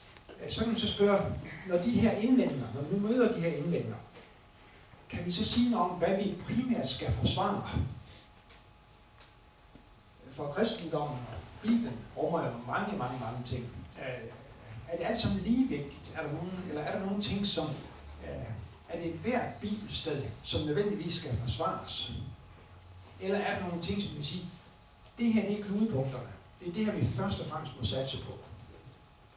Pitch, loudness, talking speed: 155 Hz, -33 LUFS, 165 wpm